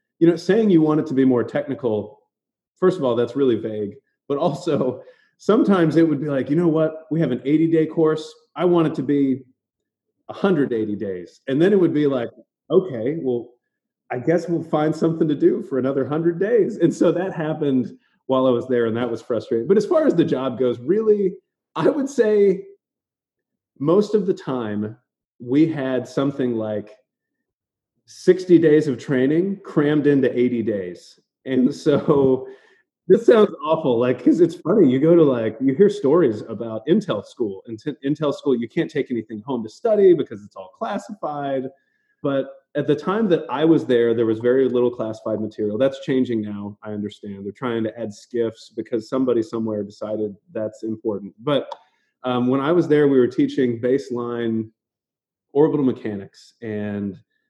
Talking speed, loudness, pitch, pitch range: 180 wpm, -20 LUFS, 135 Hz, 115-165 Hz